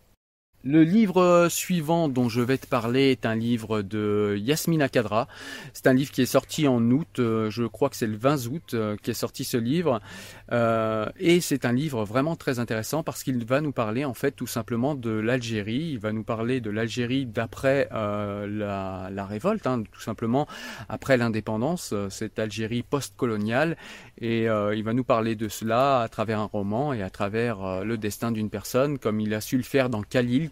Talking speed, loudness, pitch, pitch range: 195 wpm, -26 LUFS, 120 Hz, 110-135 Hz